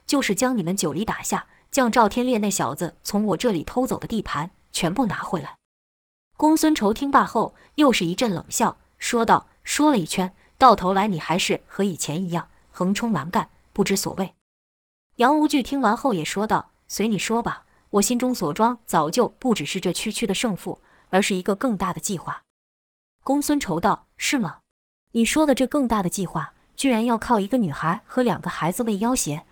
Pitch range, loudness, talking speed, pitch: 180-245 Hz, -22 LUFS, 275 characters per minute, 205 Hz